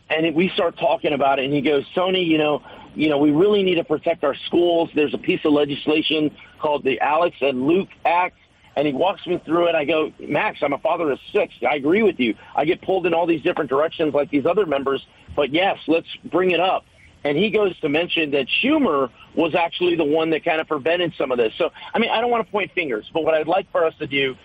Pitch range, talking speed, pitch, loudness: 145-175 Hz, 255 wpm, 160 Hz, -20 LUFS